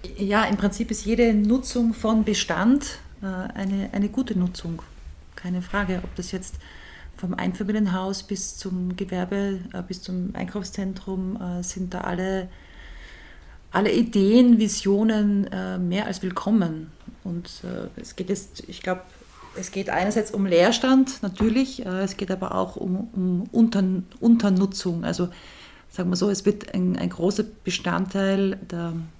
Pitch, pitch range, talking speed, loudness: 195 Hz, 185-210 Hz, 130 wpm, -24 LUFS